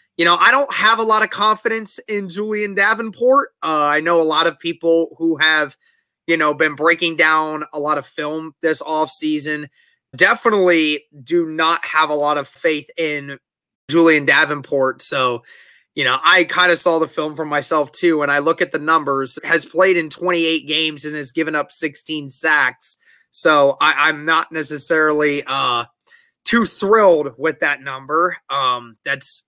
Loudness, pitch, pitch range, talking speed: -16 LUFS, 160 Hz, 150-175 Hz, 175 wpm